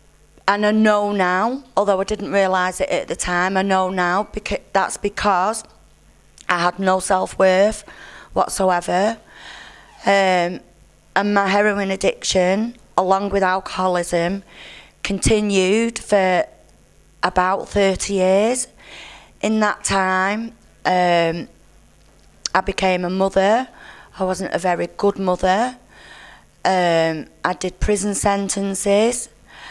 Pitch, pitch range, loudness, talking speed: 190 Hz, 185-205 Hz, -19 LUFS, 110 wpm